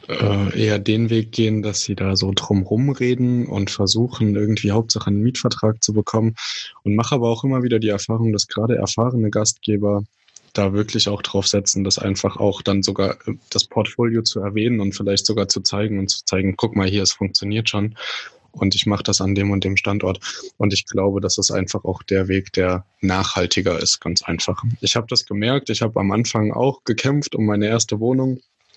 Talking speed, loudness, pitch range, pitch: 200 wpm, -19 LUFS, 100-115 Hz, 105 Hz